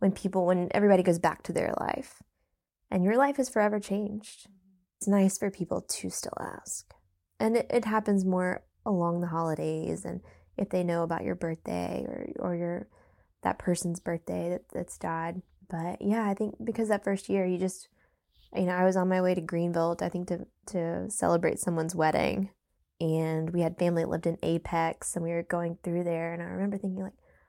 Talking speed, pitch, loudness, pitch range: 200 wpm, 180 Hz, -30 LUFS, 165-195 Hz